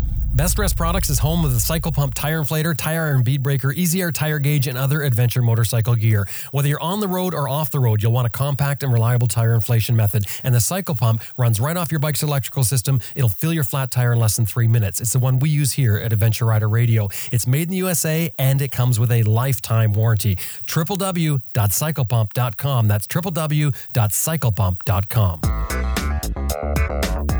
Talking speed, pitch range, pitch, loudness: 190 wpm, 115-145 Hz, 125 Hz, -19 LUFS